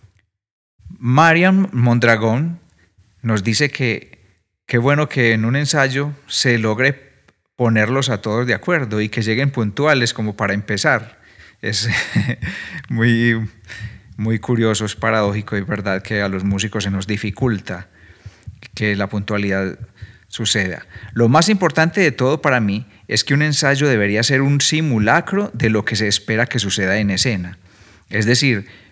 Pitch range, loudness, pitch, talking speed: 105-130 Hz, -17 LUFS, 110 Hz, 145 wpm